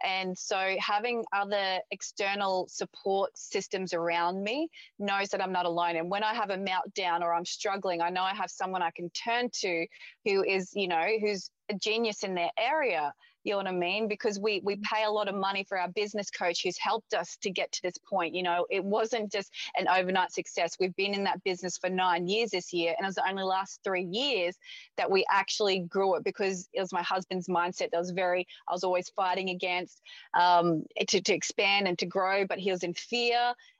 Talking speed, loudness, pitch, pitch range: 220 wpm, -30 LUFS, 190 Hz, 180-205 Hz